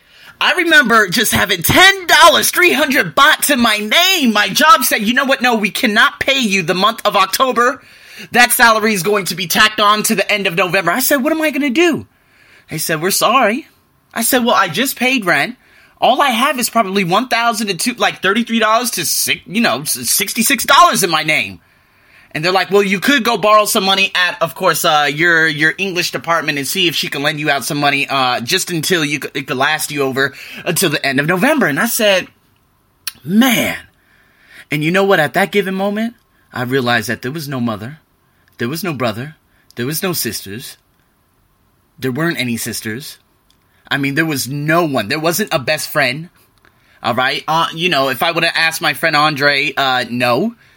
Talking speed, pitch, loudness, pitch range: 215 wpm, 190 Hz, -13 LUFS, 150-230 Hz